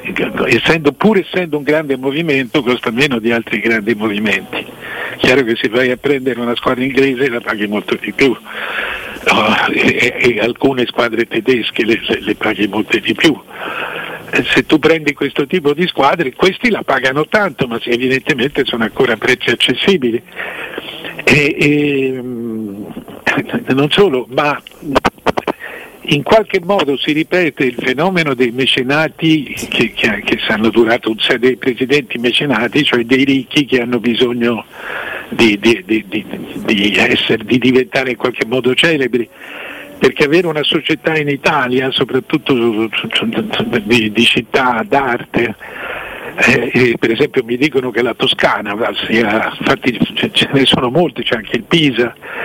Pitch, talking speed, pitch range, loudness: 130 Hz, 155 wpm, 120-150 Hz, -14 LUFS